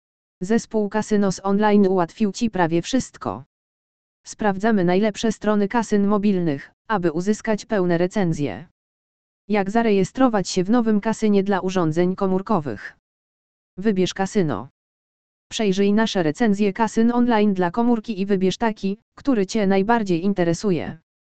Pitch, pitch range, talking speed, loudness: 200 Hz, 180-220 Hz, 115 wpm, -21 LUFS